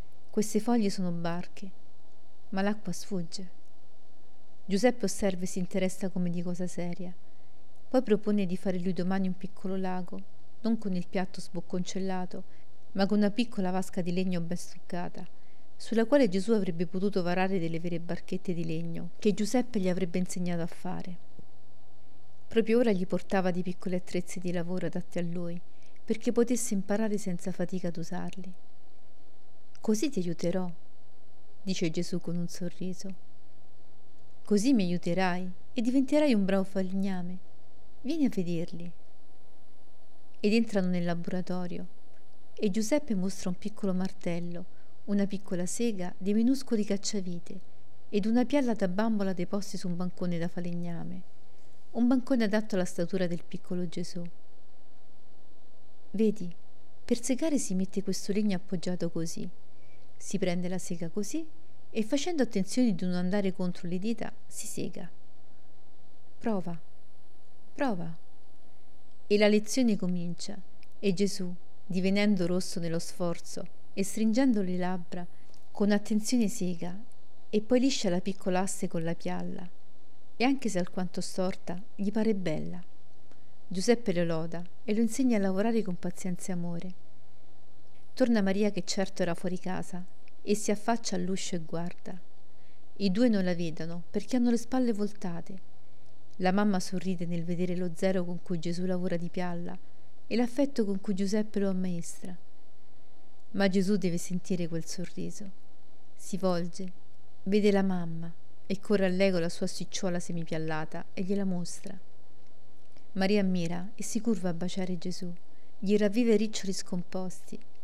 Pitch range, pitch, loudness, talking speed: 180-205 Hz, 185 Hz, -31 LUFS, 140 wpm